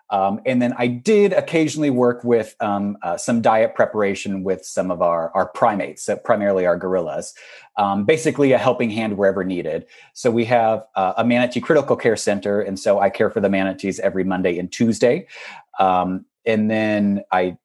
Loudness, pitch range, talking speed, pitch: -19 LUFS, 95-120 Hz, 185 wpm, 105 Hz